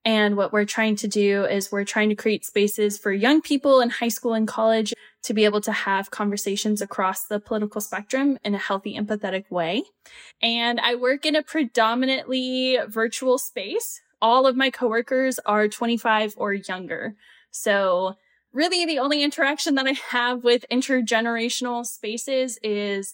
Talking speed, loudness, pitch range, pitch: 165 wpm, -23 LUFS, 210-255 Hz, 225 Hz